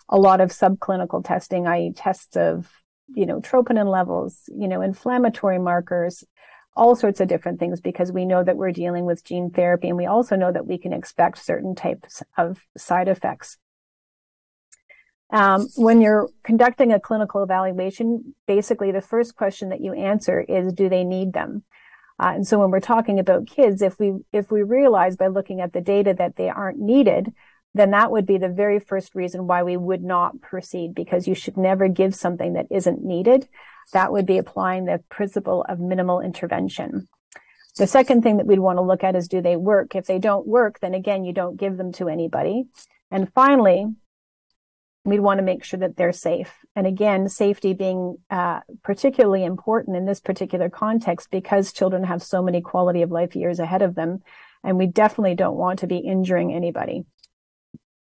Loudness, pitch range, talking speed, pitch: -21 LUFS, 180-210 Hz, 190 wpm, 190 Hz